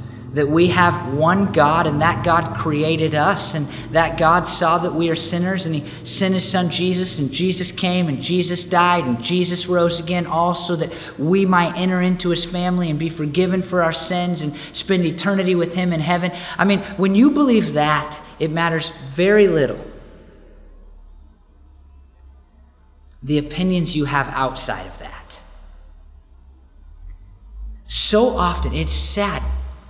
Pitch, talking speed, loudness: 165 Hz, 155 wpm, -19 LUFS